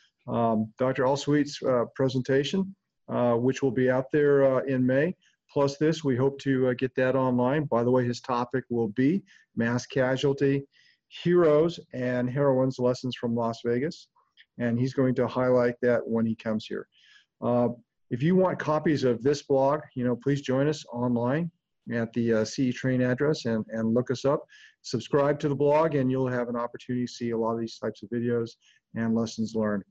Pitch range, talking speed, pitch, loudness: 120-140 Hz, 190 wpm, 130 Hz, -27 LUFS